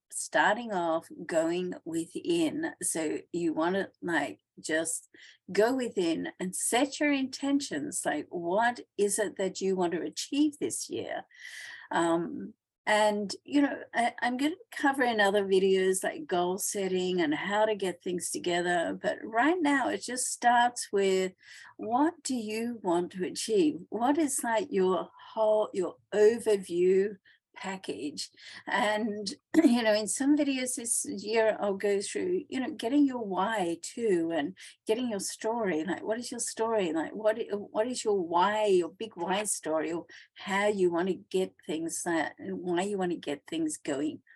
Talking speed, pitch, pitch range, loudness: 160 wpm, 215 Hz, 185-280 Hz, -30 LUFS